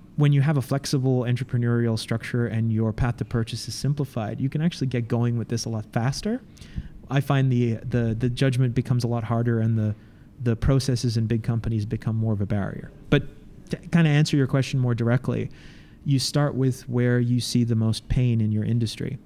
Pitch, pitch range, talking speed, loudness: 120 Hz, 115-135 Hz, 210 wpm, -24 LUFS